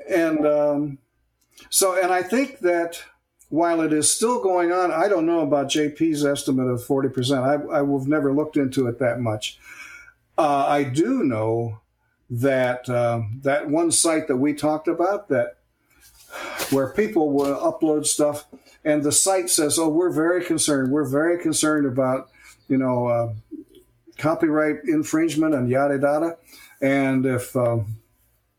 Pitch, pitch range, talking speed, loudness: 145 Hz, 130-165 Hz, 150 wpm, -21 LUFS